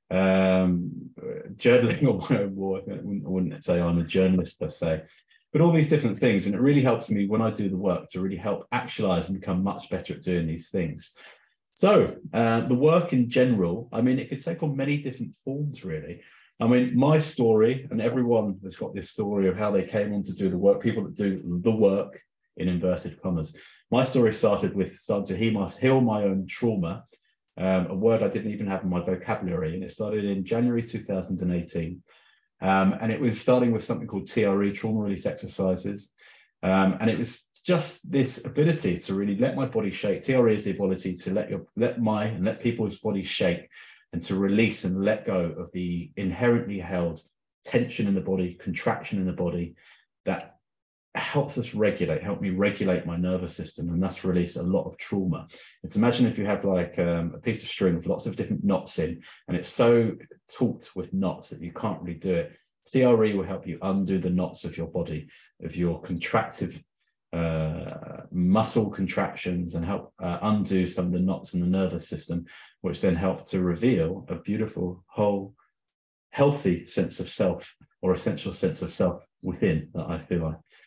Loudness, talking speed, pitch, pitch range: -26 LUFS, 200 wpm, 100 Hz, 90-115 Hz